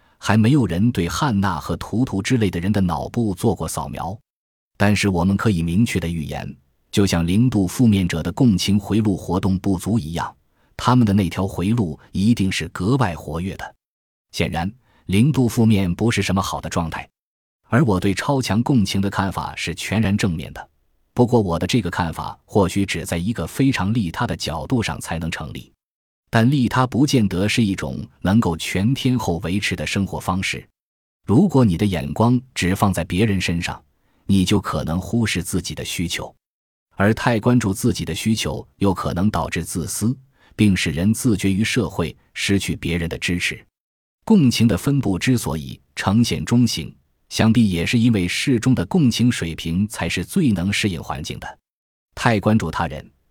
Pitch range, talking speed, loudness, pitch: 85-115 Hz, 265 characters per minute, -20 LUFS, 100 Hz